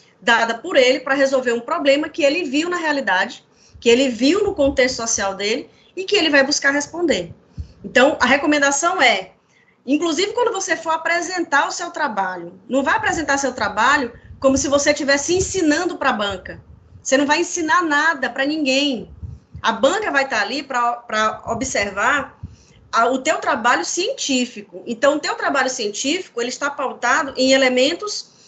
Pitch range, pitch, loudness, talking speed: 250-325 Hz, 280 Hz, -18 LUFS, 165 wpm